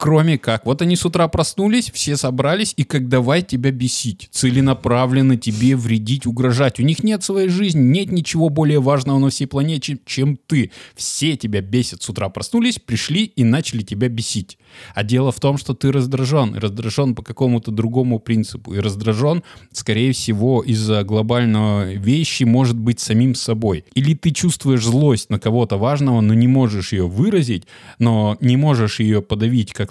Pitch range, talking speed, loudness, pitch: 115-145 Hz, 170 wpm, -17 LUFS, 125 Hz